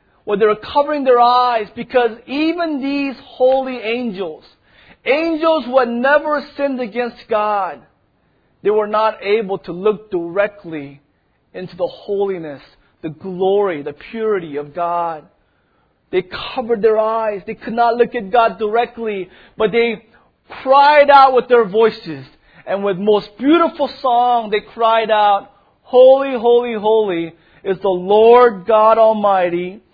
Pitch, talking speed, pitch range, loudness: 225 Hz, 135 wpm, 200-245 Hz, -15 LUFS